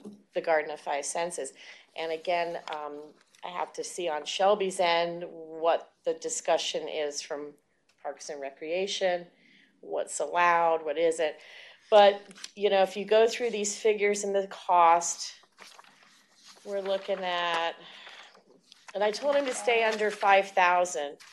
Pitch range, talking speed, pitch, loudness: 165-205 Hz, 140 wpm, 185 Hz, -28 LUFS